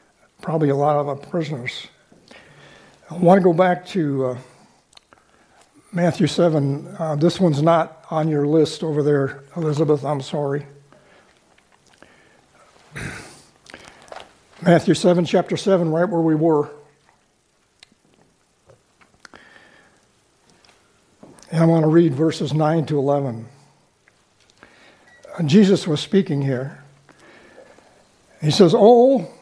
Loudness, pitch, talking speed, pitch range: -18 LUFS, 160 Hz, 100 wpm, 145-175 Hz